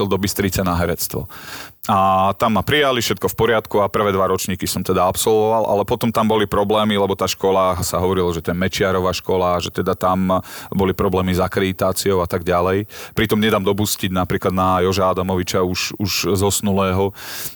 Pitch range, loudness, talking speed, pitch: 95-100 Hz, -18 LUFS, 185 wpm, 95 Hz